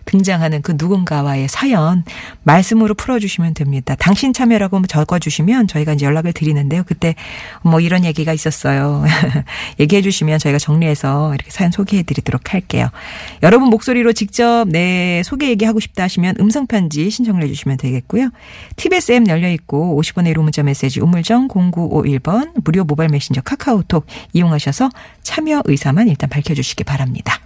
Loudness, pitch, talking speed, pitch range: -15 LUFS, 170 Hz, 390 characters per minute, 150-205 Hz